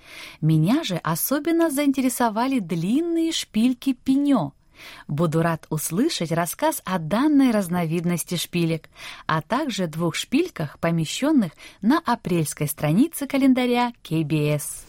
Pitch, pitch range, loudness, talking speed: 205 Hz, 165-275 Hz, -23 LUFS, 100 wpm